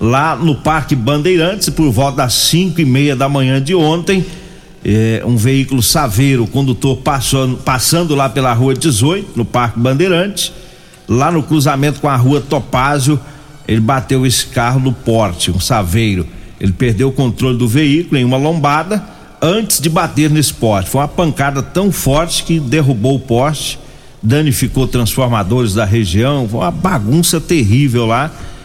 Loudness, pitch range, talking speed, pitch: -13 LUFS, 120-155 Hz, 160 wpm, 135 Hz